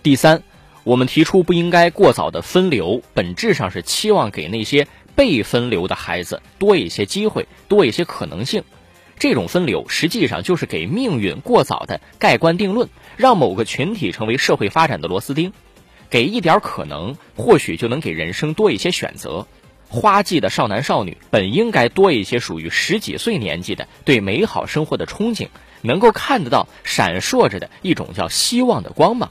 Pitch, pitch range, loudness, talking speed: 170 Hz, 150-205 Hz, -17 LUFS, 280 characters per minute